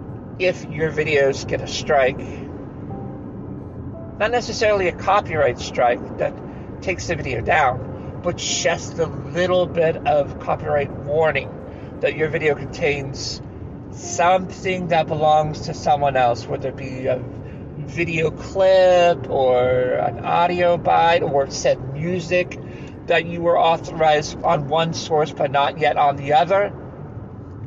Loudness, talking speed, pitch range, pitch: -20 LUFS, 130 wpm, 135-170 Hz, 150 Hz